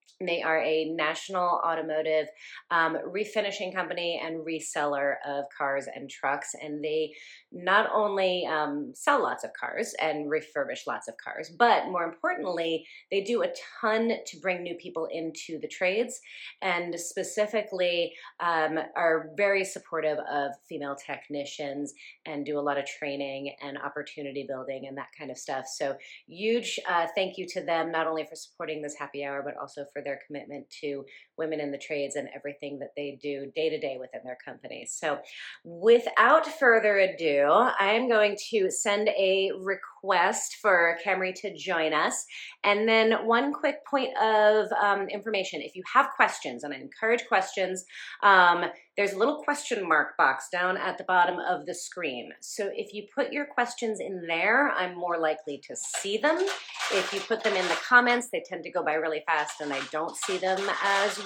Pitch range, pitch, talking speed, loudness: 150-205 Hz, 170 Hz, 175 wpm, -27 LUFS